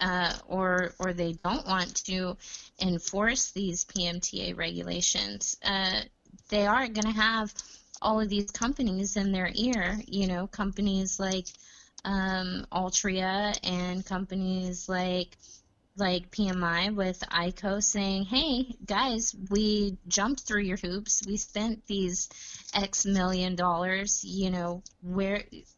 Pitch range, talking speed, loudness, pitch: 180-205 Hz, 130 wpm, -29 LUFS, 190 Hz